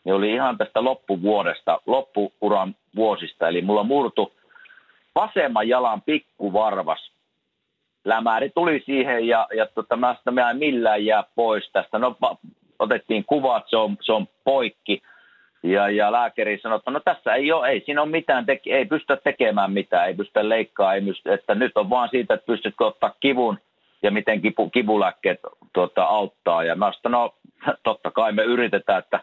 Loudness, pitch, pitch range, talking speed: -22 LUFS, 110 Hz, 105-125 Hz, 160 wpm